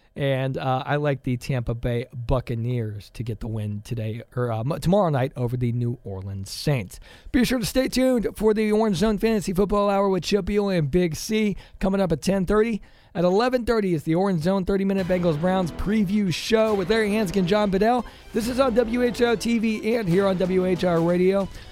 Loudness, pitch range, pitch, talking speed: -23 LUFS, 130-215 Hz, 190 Hz, 195 wpm